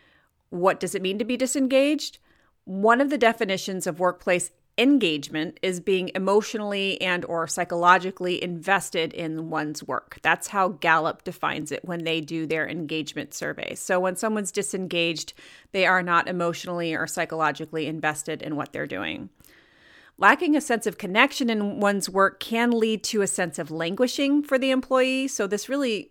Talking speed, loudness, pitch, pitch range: 165 wpm, -24 LUFS, 185 Hz, 170-220 Hz